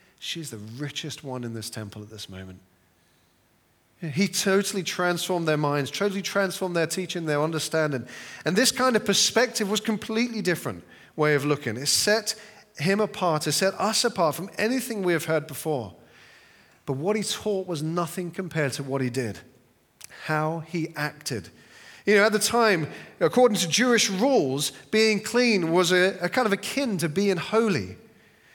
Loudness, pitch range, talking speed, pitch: -25 LUFS, 145-205 Hz, 170 wpm, 175 Hz